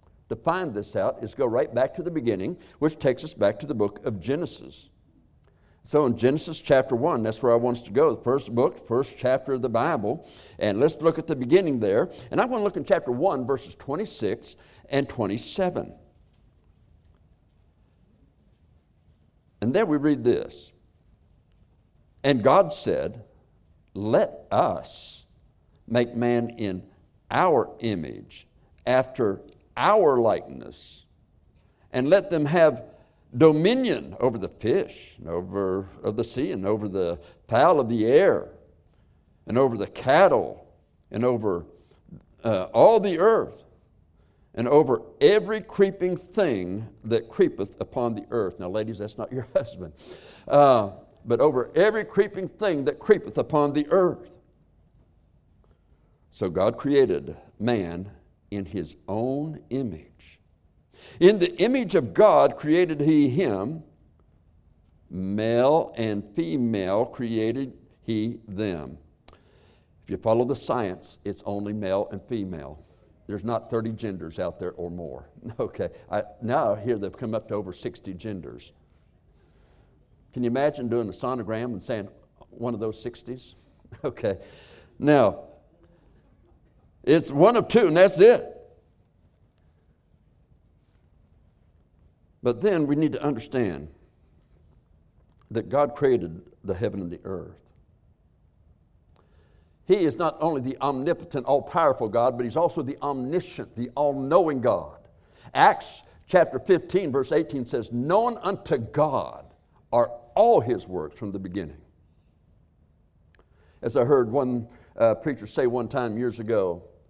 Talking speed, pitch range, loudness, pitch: 135 wpm, 90-145 Hz, -24 LUFS, 115 Hz